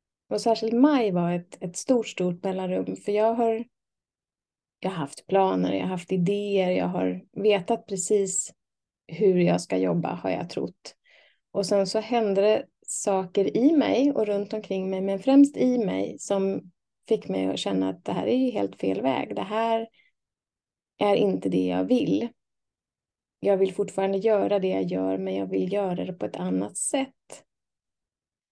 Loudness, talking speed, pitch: -25 LUFS, 175 wpm, 195 Hz